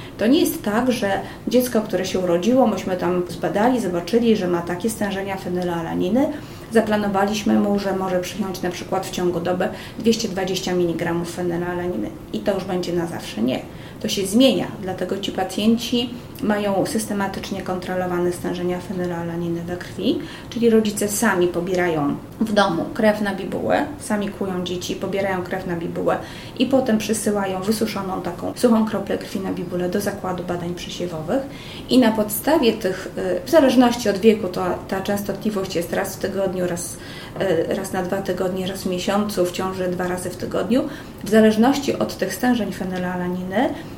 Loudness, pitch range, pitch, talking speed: -21 LUFS, 180-220 Hz, 195 Hz, 155 wpm